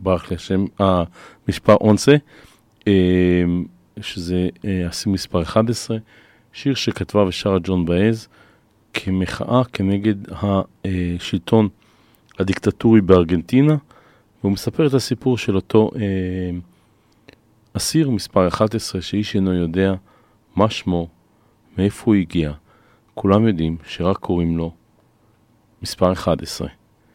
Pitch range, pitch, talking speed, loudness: 90-110 Hz, 100 Hz, 100 wpm, -19 LUFS